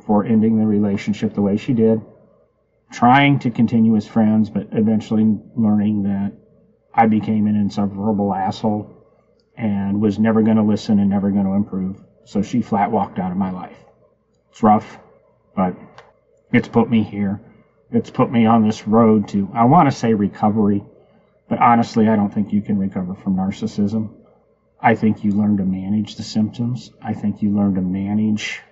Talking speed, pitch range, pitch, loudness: 175 wpm, 100-115 Hz, 110 Hz, -18 LUFS